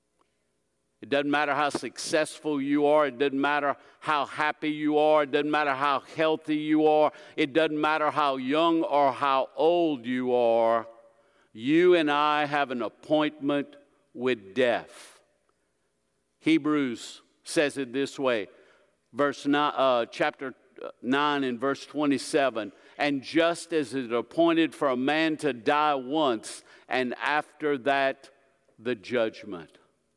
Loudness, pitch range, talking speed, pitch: -26 LUFS, 135-150 Hz, 135 wpm, 145 Hz